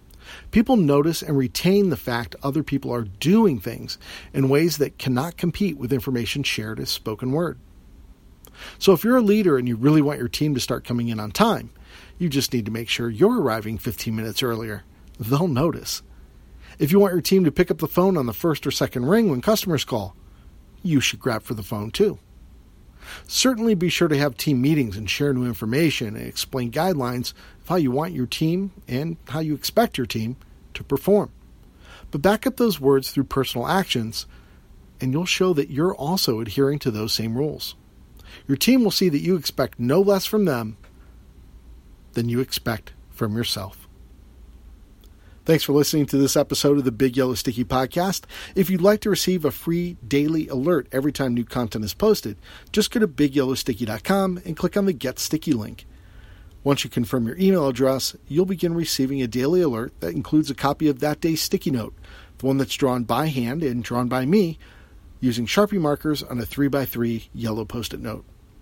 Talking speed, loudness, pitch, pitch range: 195 wpm, -22 LUFS, 135 Hz, 115-165 Hz